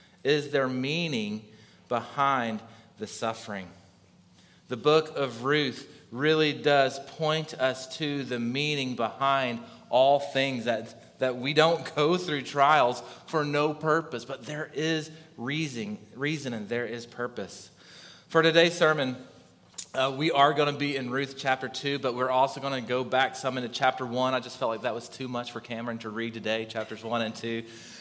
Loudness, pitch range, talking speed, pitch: -28 LUFS, 120-150 Hz, 170 wpm, 130 Hz